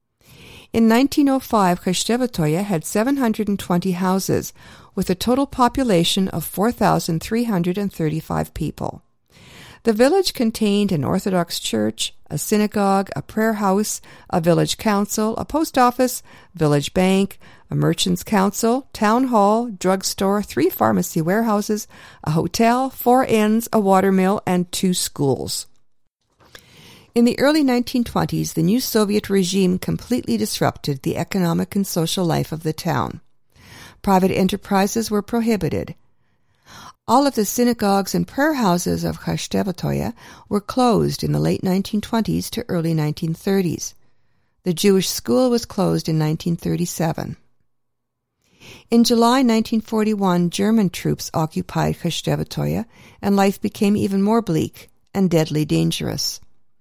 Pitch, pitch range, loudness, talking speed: 195 Hz, 165-225 Hz, -20 LUFS, 120 wpm